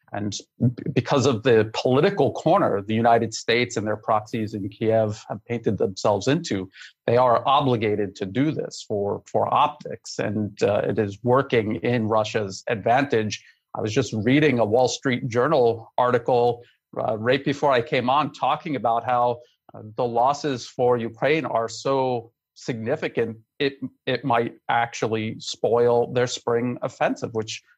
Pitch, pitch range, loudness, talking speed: 120 Hz, 110-125 Hz, -23 LUFS, 150 wpm